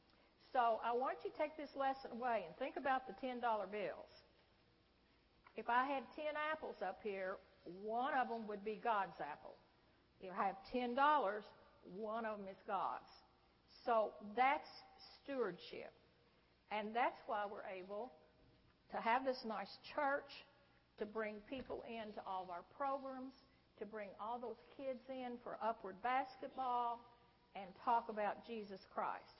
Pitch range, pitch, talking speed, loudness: 210-260 Hz, 235 Hz, 155 wpm, -43 LUFS